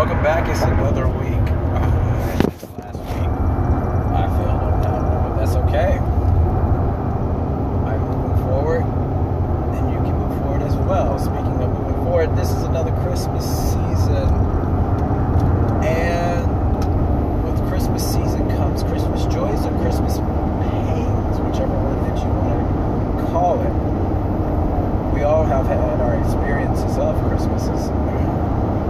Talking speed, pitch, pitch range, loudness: 125 wpm, 95 Hz, 90-105 Hz, -19 LUFS